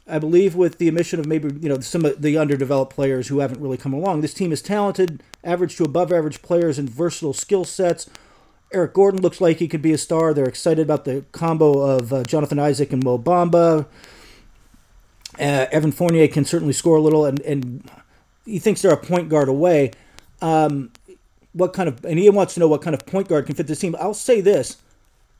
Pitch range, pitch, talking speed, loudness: 140-175 Hz, 155 Hz, 215 wpm, -19 LUFS